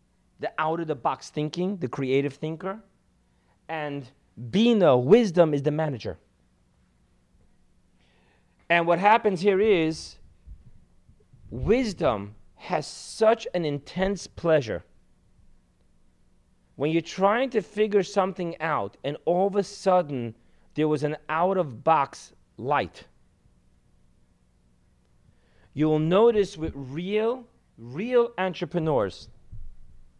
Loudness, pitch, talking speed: -25 LUFS, 155 Hz, 95 wpm